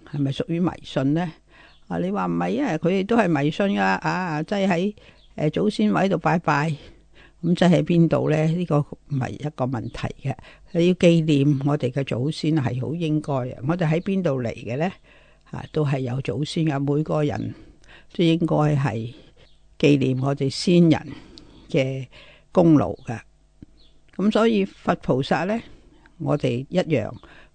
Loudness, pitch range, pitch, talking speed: -22 LUFS, 140-170 Hz, 150 Hz, 230 characters per minute